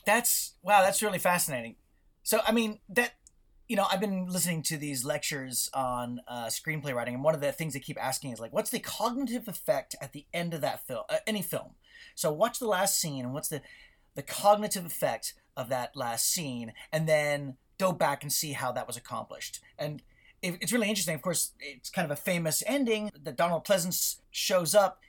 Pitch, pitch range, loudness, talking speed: 170 Hz, 145-205 Hz, -30 LUFS, 210 wpm